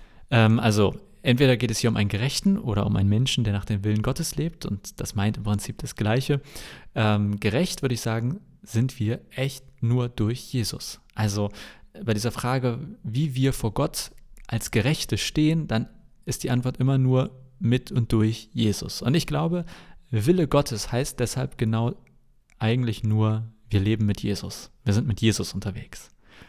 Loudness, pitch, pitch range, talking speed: -25 LUFS, 120 Hz, 110-130 Hz, 170 wpm